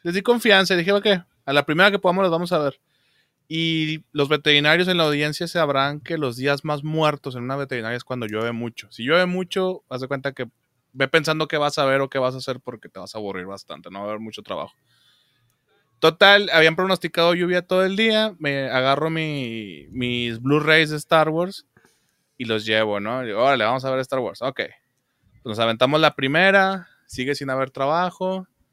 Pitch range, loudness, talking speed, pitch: 130-175 Hz, -20 LUFS, 210 wpm, 145 Hz